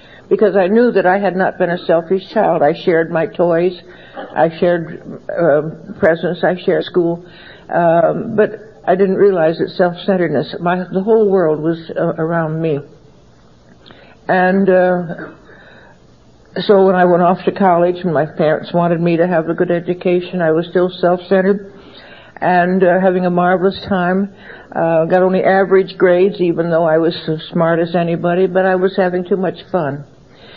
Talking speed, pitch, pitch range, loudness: 170 wpm, 180 Hz, 165-190 Hz, -15 LUFS